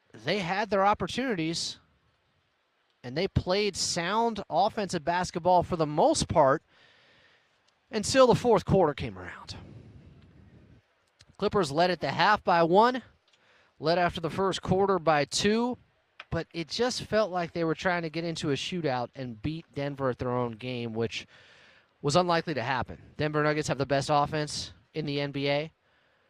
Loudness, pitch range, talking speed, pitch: -28 LUFS, 140-195 Hz, 155 wpm, 165 Hz